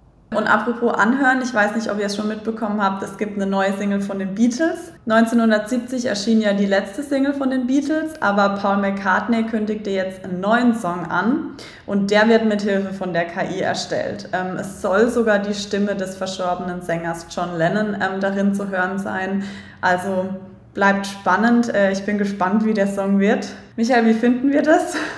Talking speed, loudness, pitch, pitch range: 180 wpm, -20 LUFS, 205 Hz, 195-230 Hz